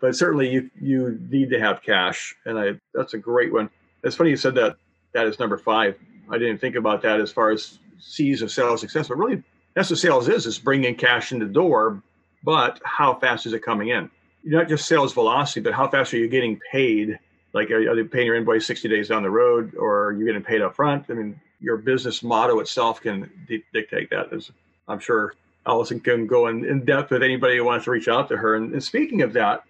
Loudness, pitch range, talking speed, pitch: -22 LUFS, 110-130 Hz, 240 wpm, 120 Hz